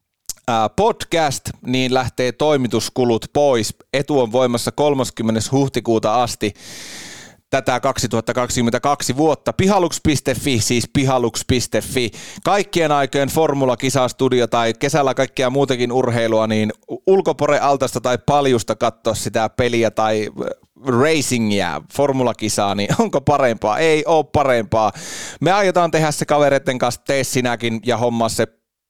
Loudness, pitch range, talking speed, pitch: -18 LUFS, 115-140 Hz, 110 wpm, 125 Hz